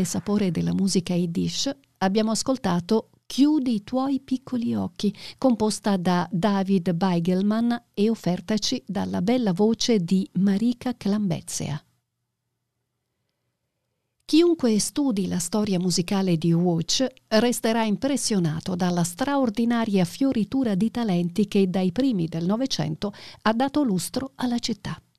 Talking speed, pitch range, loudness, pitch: 110 wpm, 180-235 Hz, -24 LUFS, 205 Hz